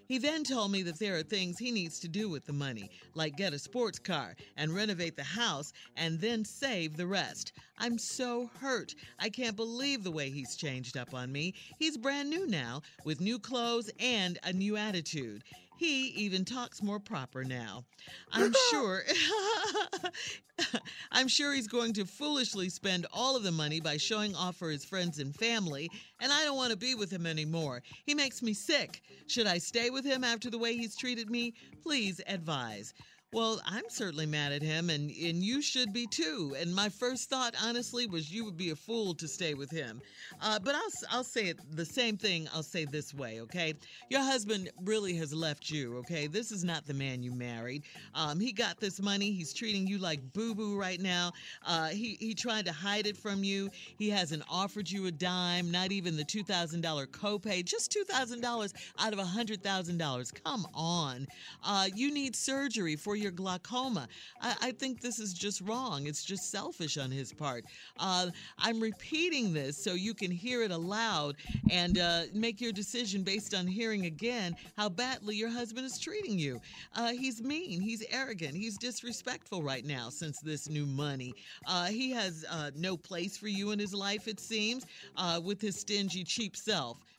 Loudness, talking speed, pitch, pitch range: -34 LUFS, 195 wpm, 195 Hz, 160-230 Hz